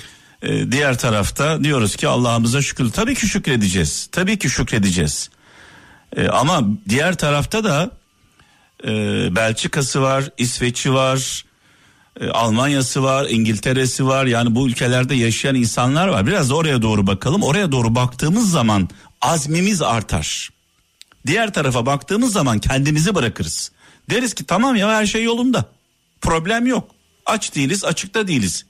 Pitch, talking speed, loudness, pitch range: 135 Hz, 130 wpm, -18 LUFS, 115-170 Hz